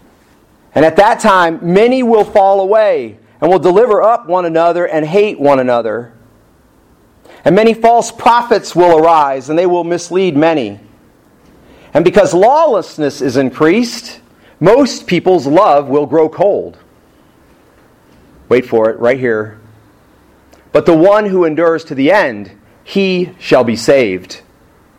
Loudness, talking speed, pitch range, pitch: -11 LUFS, 135 wpm, 130-195 Hz, 165 Hz